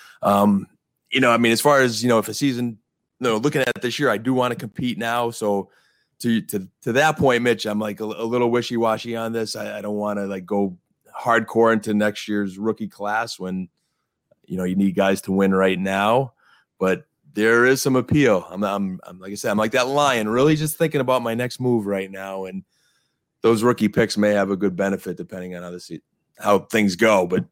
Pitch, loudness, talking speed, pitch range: 110 Hz, -21 LUFS, 230 wpm, 100-120 Hz